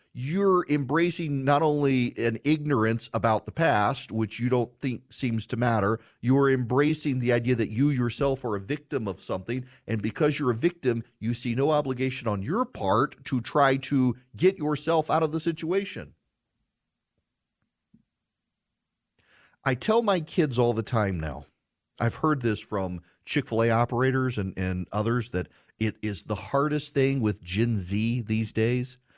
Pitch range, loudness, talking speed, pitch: 110-145 Hz, -26 LUFS, 160 wpm, 125 Hz